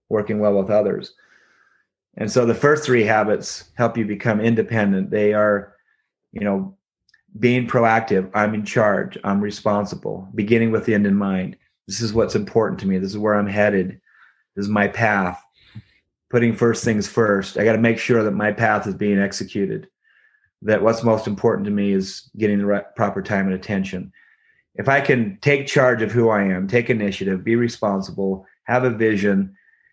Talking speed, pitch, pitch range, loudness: 180 wpm, 105 Hz, 100-115 Hz, -20 LUFS